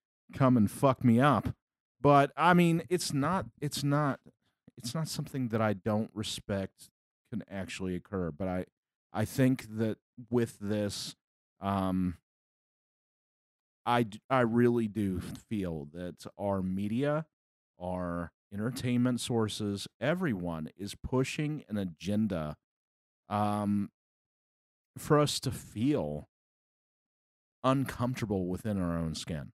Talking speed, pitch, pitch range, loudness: 115 wpm, 105 Hz, 95-130 Hz, -31 LUFS